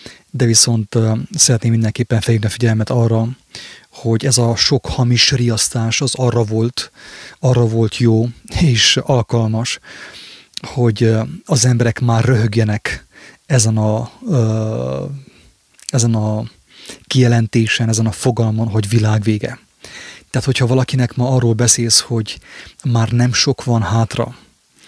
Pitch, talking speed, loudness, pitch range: 115 Hz, 120 wpm, -15 LUFS, 110-125 Hz